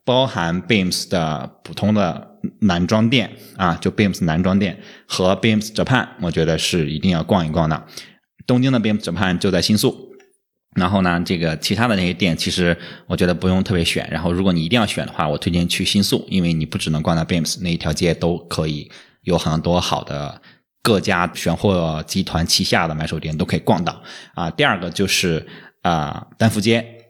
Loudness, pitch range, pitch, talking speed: -19 LUFS, 85-105 Hz, 90 Hz, 335 characters per minute